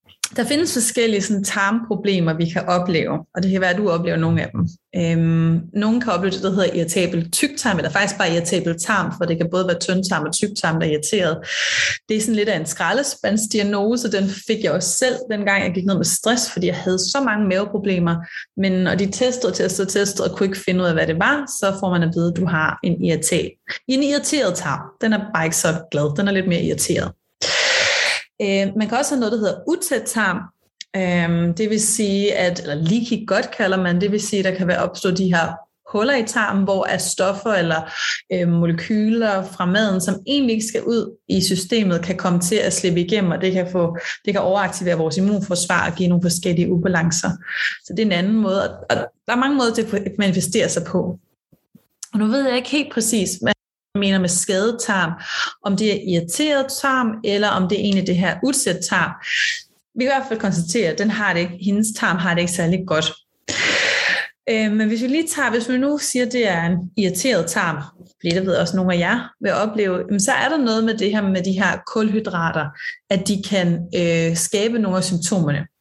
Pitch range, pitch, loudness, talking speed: 175-220 Hz, 195 Hz, -19 LUFS, 220 wpm